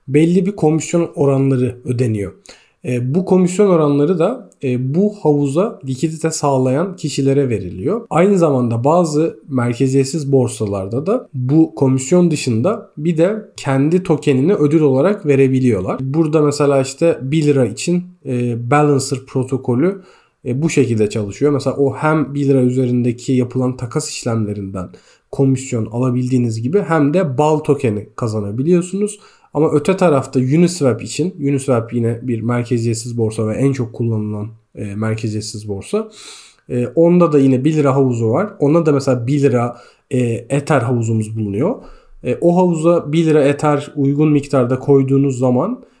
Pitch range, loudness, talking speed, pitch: 125-155 Hz, -16 LUFS, 140 wpm, 135 Hz